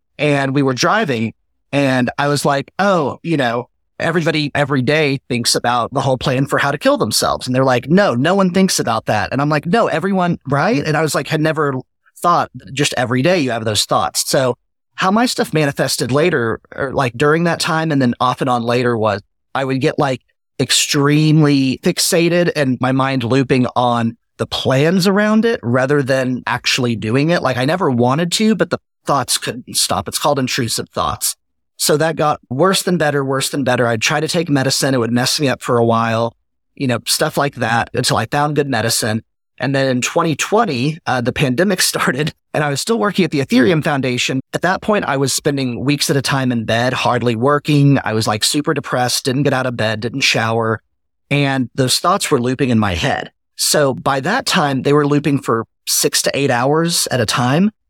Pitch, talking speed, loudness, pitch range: 140 Hz, 210 wpm, -16 LUFS, 125-155 Hz